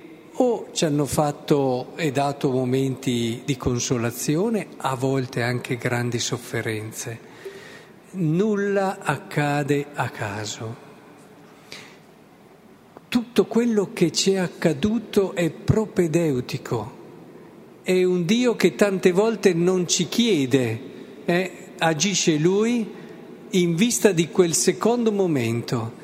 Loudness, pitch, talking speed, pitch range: -22 LUFS, 170 Hz, 100 wpm, 135-200 Hz